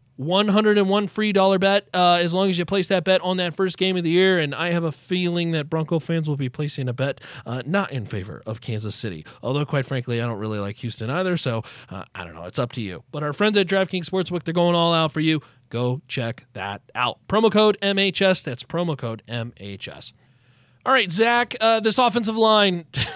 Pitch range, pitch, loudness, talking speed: 125-190 Hz, 160 Hz, -22 LUFS, 225 wpm